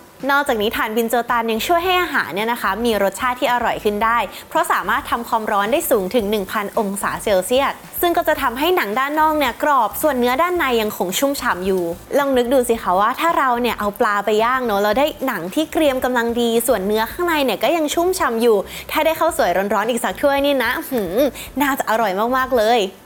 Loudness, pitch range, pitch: -18 LUFS, 220-295 Hz, 250 Hz